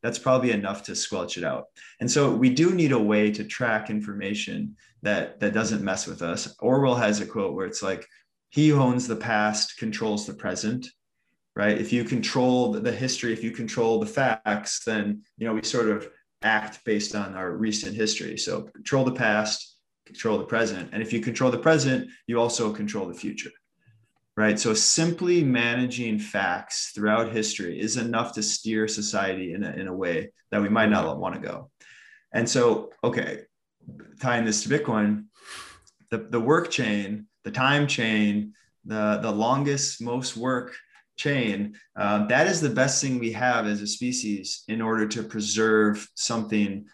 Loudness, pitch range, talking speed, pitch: -25 LUFS, 105-125 Hz, 175 wpm, 110 Hz